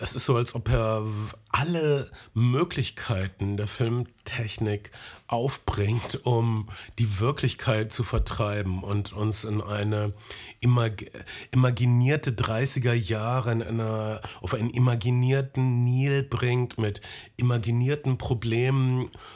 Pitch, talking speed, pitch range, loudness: 120 Hz, 105 wpm, 110-125 Hz, -26 LUFS